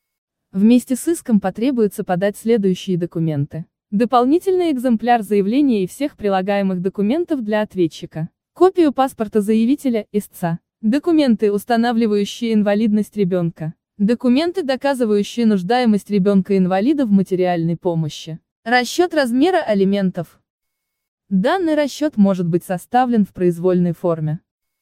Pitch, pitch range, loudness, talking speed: 210 Hz, 185-250 Hz, -18 LUFS, 105 wpm